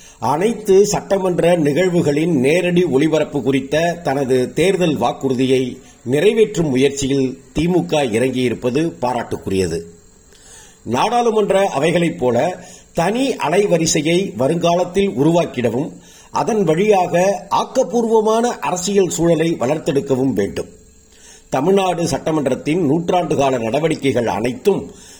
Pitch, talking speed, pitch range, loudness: 160 Hz, 80 wpm, 135-185 Hz, -17 LUFS